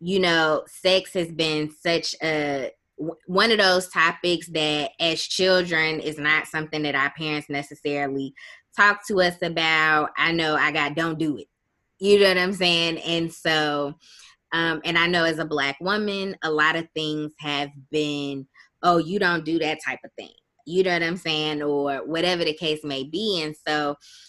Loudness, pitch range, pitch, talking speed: -22 LUFS, 150-175 Hz, 160 Hz, 185 wpm